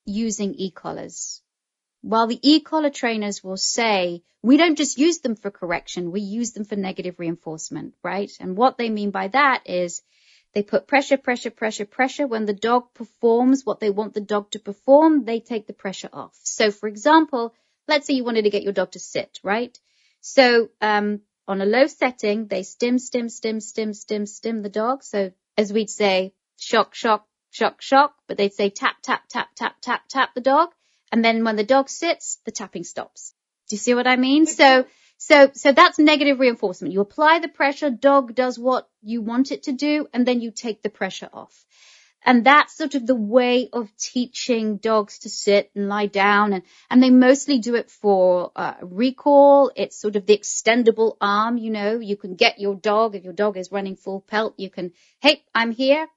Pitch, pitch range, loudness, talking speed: 225 Hz, 205-260 Hz, -20 LUFS, 200 wpm